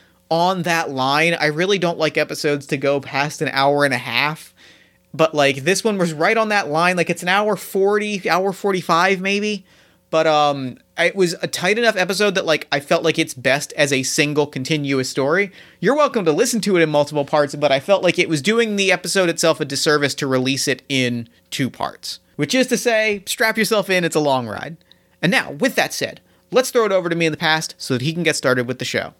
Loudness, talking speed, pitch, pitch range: -18 LUFS, 235 wpm, 160 Hz, 145-195 Hz